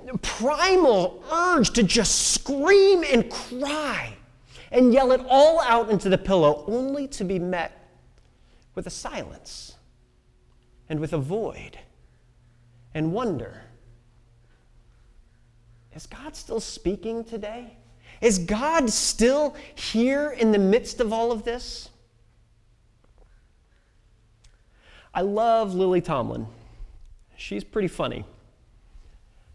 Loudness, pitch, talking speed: -23 LUFS, 190 Hz, 105 wpm